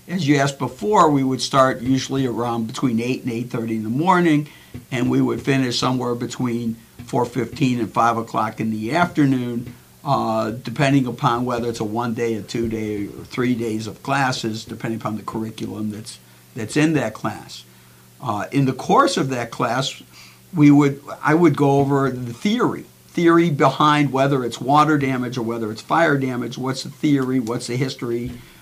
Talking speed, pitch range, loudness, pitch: 185 wpm, 115-140 Hz, -20 LUFS, 125 Hz